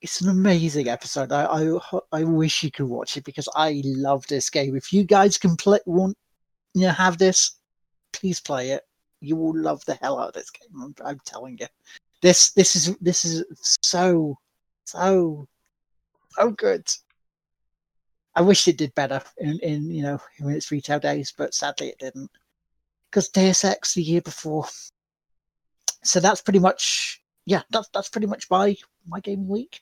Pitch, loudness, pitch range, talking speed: 170 Hz, -21 LUFS, 150-190 Hz, 175 wpm